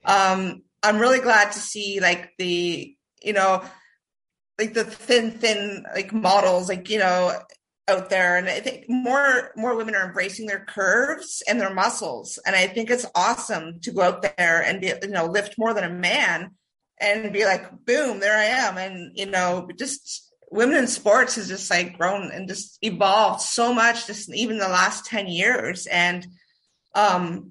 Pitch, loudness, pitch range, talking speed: 200 Hz, -22 LUFS, 185-225 Hz, 180 wpm